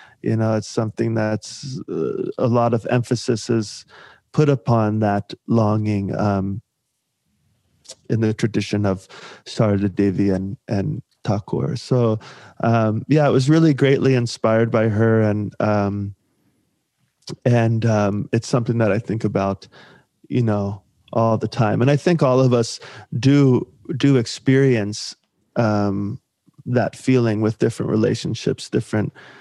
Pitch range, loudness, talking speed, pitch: 105-130 Hz, -20 LUFS, 135 wpm, 115 Hz